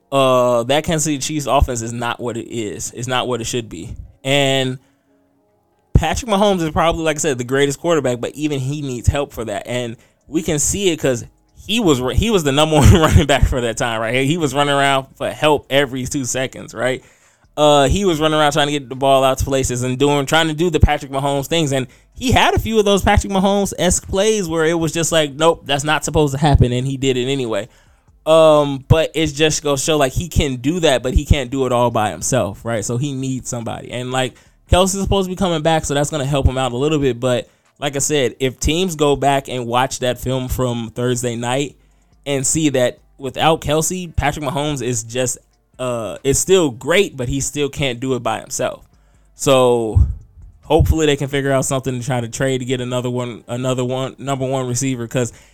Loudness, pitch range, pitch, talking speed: -17 LUFS, 125-150 Hz, 135 Hz, 230 wpm